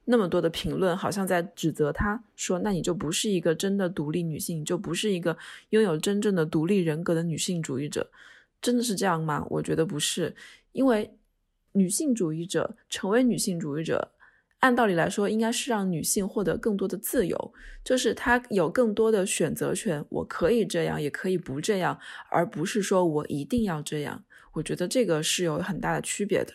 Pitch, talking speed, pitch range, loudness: 185 Hz, 305 characters per minute, 165-215 Hz, -27 LUFS